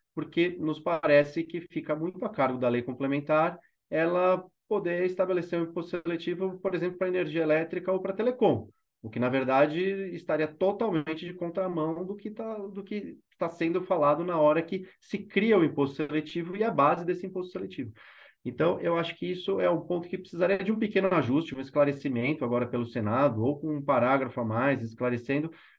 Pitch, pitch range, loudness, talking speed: 170 Hz, 145-185 Hz, -29 LUFS, 185 wpm